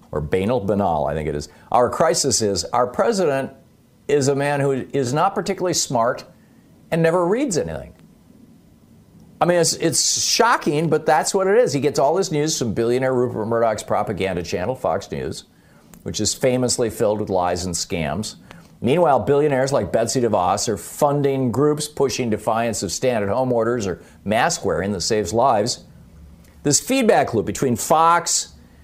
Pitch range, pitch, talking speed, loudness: 105-155 Hz, 130 Hz, 165 wpm, -20 LUFS